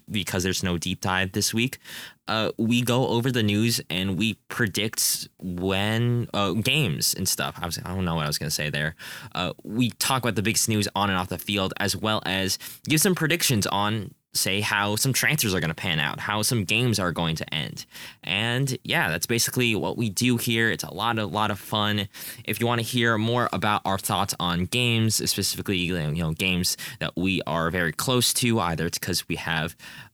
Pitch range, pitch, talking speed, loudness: 95-120 Hz, 105 Hz, 215 wpm, -24 LUFS